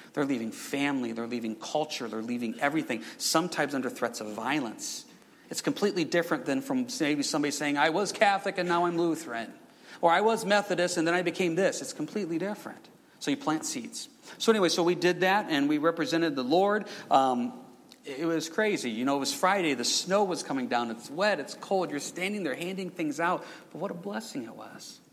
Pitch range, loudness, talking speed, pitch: 145-200 Hz, -29 LUFS, 205 wpm, 170 Hz